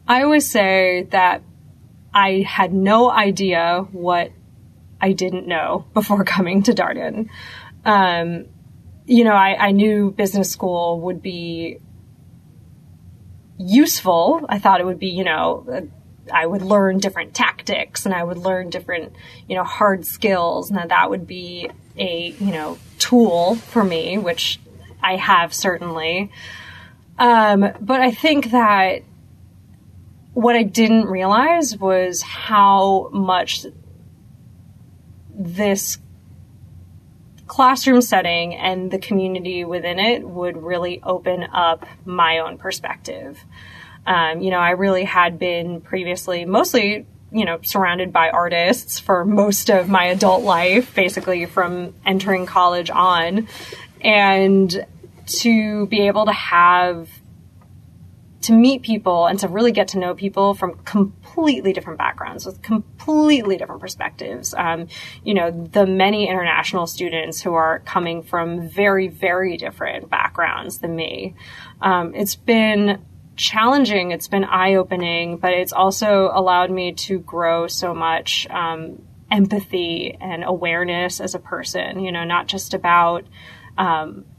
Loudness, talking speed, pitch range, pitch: -18 LUFS, 130 wpm, 170-200 Hz, 185 Hz